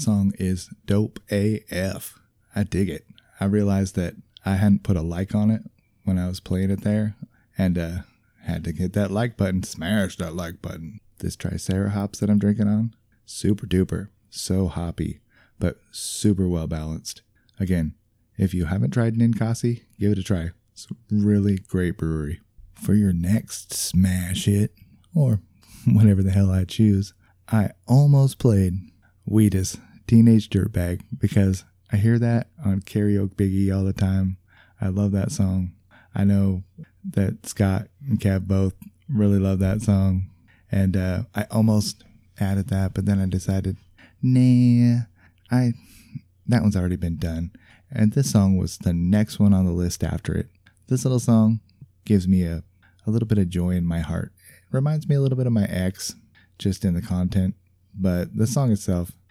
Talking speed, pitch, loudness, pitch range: 165 wpm, 100 Hz, -23 LUFS, 95-110 Hz